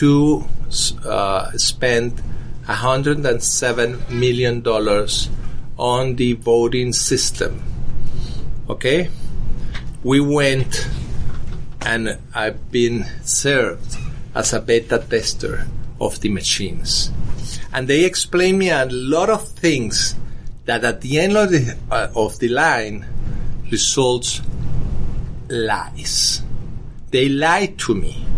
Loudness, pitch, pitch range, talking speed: -19 LUFS, 125 Hz, 120-140 Hz, 100 wpm